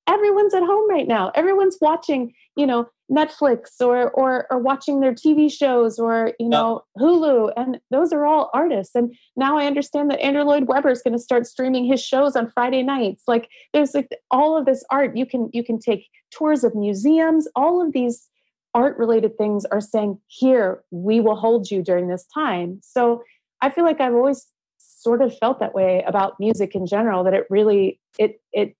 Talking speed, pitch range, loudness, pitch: 200 wpm, 225-290 Hz, -20 LUFS, 255 Hz